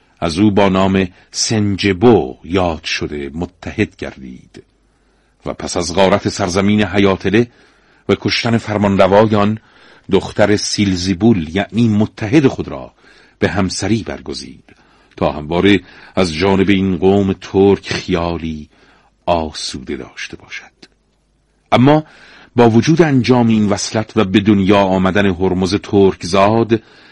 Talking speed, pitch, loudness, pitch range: 115 wpm, 100 Hz, -14 LUFS, 95-110 Hz